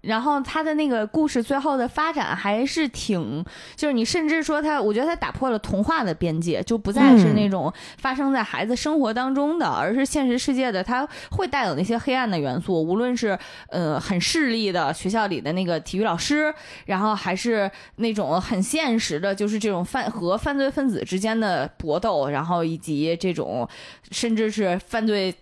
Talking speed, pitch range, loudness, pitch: 290 characters per minute, 185-275 Hz, -23 LUFS, 225 Hz